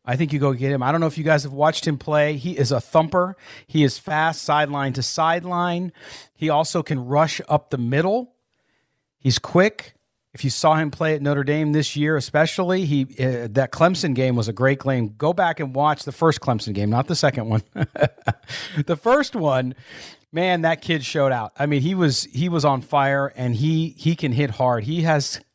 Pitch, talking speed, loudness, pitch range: 150 Hz, 215 wpm, -21 LUFS, 135-160 Hz